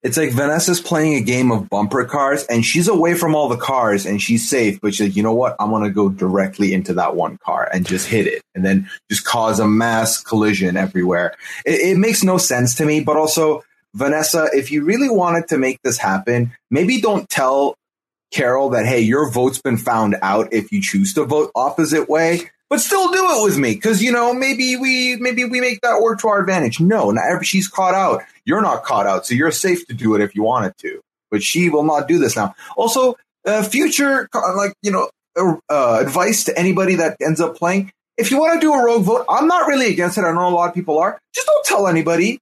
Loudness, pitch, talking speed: -16 LUFS, 165 Hz, 235 wpm